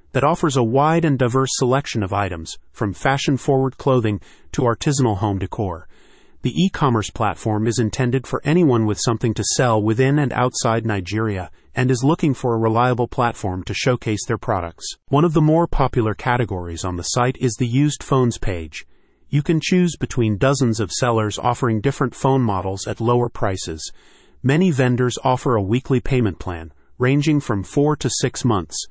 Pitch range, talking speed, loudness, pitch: 110-135 Hz, 175 wpm, -20 LUFS, 120 Hz